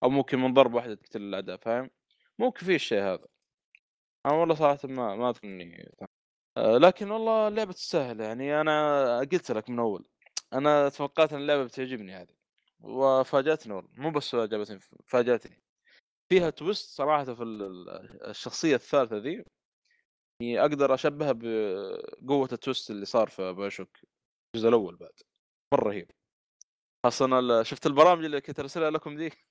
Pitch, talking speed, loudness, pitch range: 135 Hz, 135 wpm, -27 LUFS, 115-155 Hz